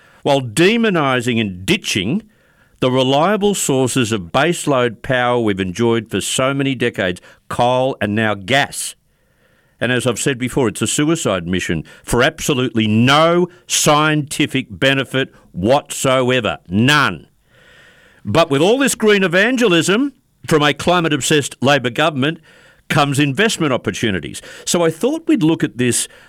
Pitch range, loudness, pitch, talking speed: 120-165 Hz, -16 LUFS, 135 Hz, 130 wpm